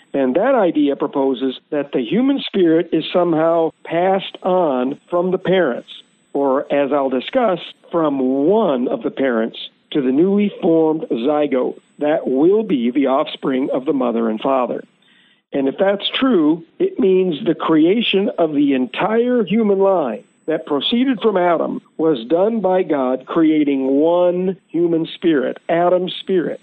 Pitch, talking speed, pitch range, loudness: 170 Hz, 150 wpm, 145-195 Hz, -17 LUFS